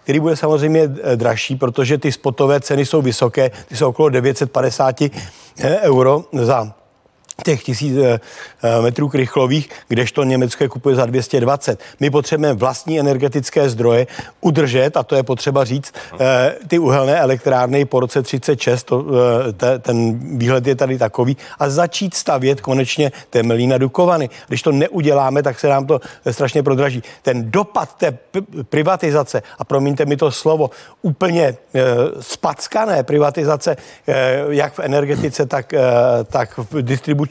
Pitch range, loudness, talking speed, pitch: 130-150 Hz, -16 LUFS, 145 wpm, 140 Hz